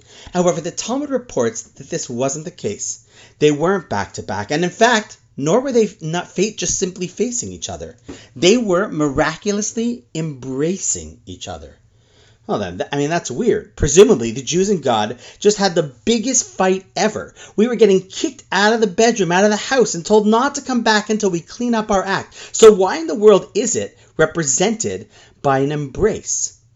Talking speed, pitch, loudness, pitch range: 190 wpm, 175 Hz, -17 LUFS, 130-210 Hz